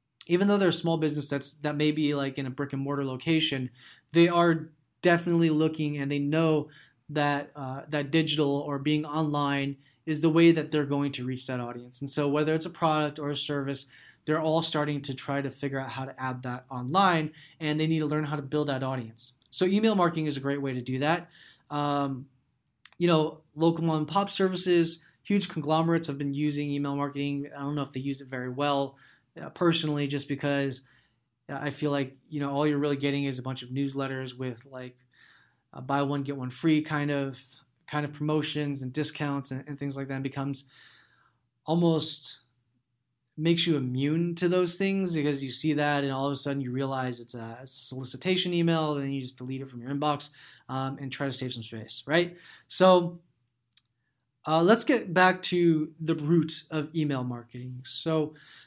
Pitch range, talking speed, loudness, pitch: 135-155 Hz, 200 wpm, -27 LUFS, 145 Hz